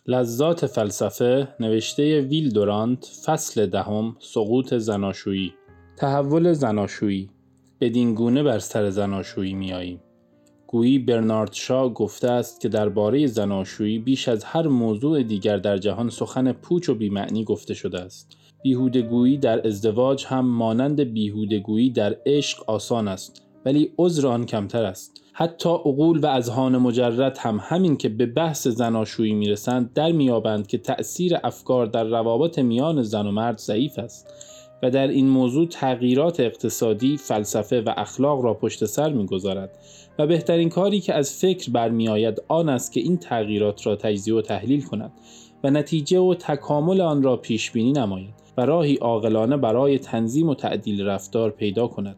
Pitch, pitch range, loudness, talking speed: 120 Hz, 105-140 Hz, -22 LUFS, 150 wpm